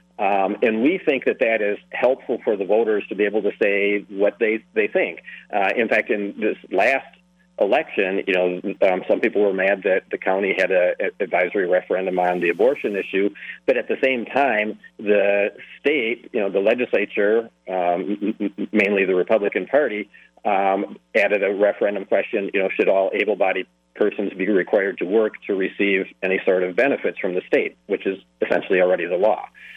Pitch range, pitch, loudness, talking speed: 95-135 Hz, 105 Hz, -21 LUFS, 185 wpm